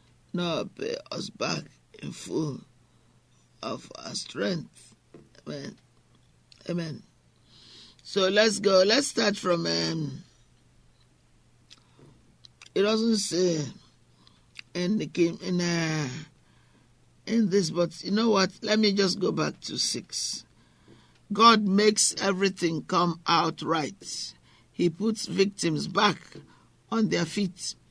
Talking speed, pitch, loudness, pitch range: 110 wpm, 180 Hz, -26 LUFS, 155-205 Hz